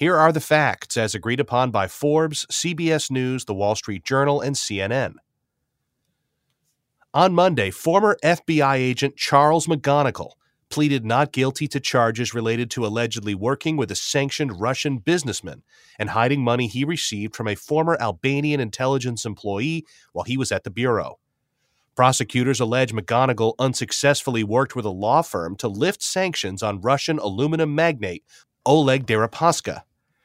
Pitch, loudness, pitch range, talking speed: 130 Hz, -21 LUFS, 115-150 Hz, 145 wpm